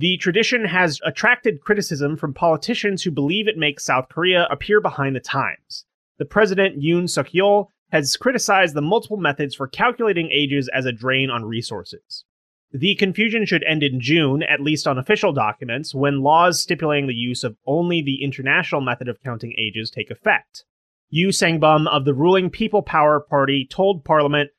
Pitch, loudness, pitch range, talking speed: 155 Hz, -19 LUFS, 140-190 Hz, 170 wpm